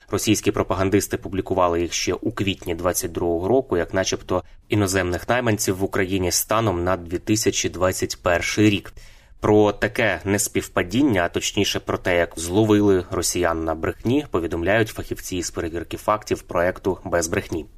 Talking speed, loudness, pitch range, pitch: 130 wpm, -22 LUFS, 90-105 Hz, 95 Hz